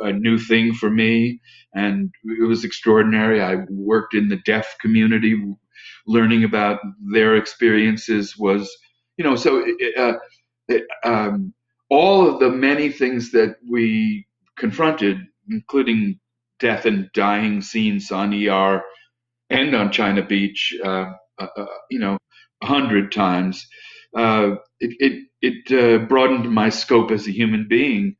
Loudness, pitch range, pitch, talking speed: -19 LUFS, 100-120 Hz, 110 Hz, 140 wpm